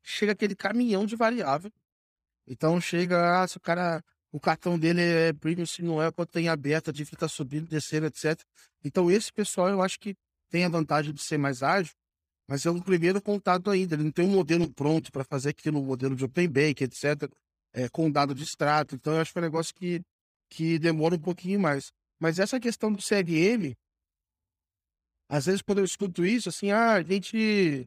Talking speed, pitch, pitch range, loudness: 205 wpm, 165 Hz, 145-185 Hz, -27 LUFS